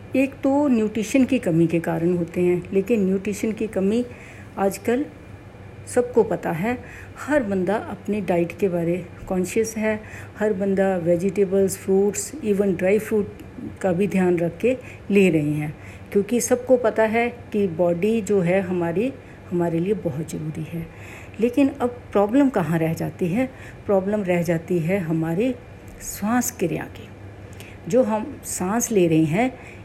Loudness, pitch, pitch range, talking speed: -22 LUFS, 195 Hz, 175-225 Hz, 150 wpm